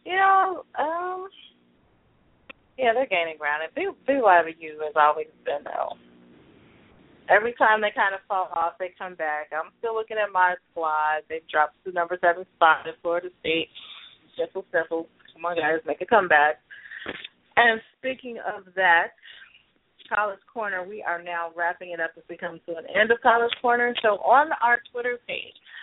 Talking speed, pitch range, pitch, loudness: 170 wpm, 165-235 Hz, 180 Hz, -24 LUFS